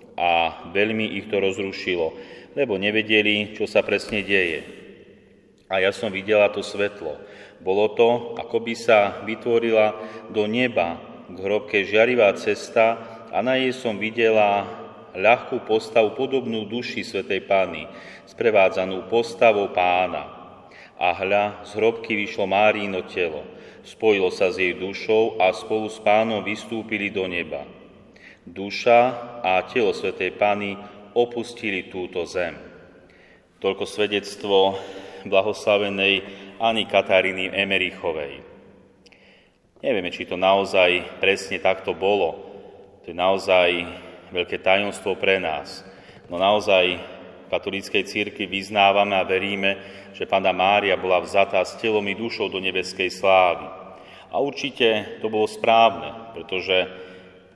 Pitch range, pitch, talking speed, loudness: 95-110 Hz, 100 Hz, 120 wpm, -22 LUFS